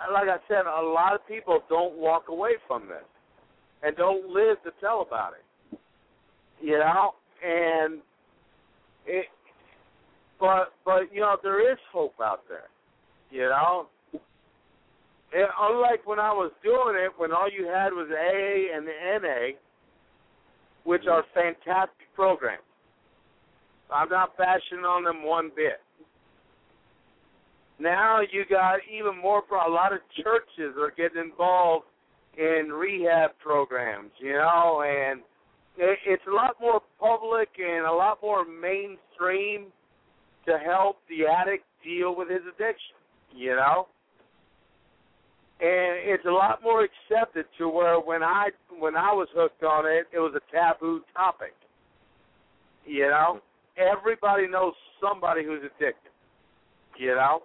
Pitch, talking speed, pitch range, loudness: 180 Hz, 140 wpm, 160-200 Hz, -26 LUFS